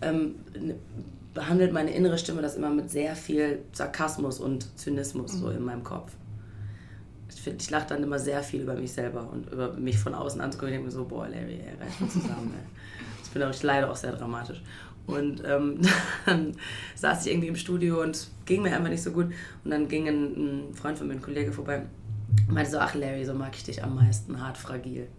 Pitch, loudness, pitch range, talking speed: 135 Hz, -29 LUFS, 110-150 Hz, 205 wpm